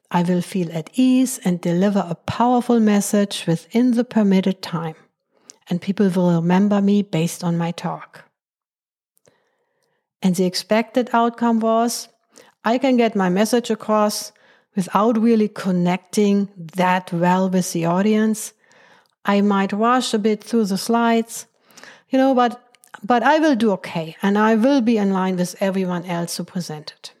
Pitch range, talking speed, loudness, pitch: 180-230 Hz, 150 wpm, -19 LUFS, 205 Hz